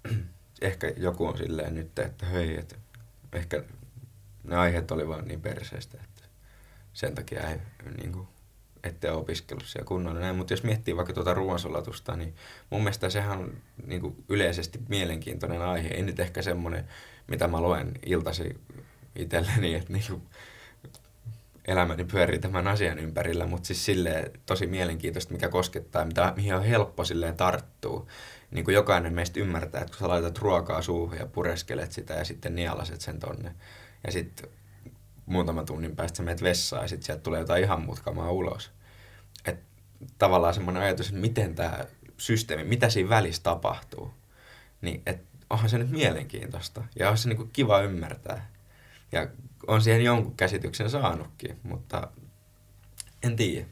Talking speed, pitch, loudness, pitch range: 155 wpm, 100 Hz, -29 LUFS, 90-115 Hz